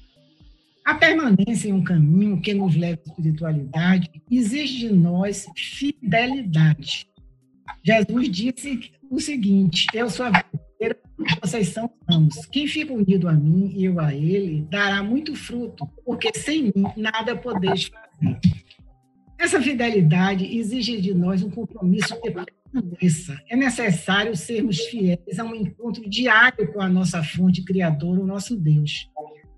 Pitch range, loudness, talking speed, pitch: 170-230 Hz, -21 LUFS, 140 wpm, 195 Hz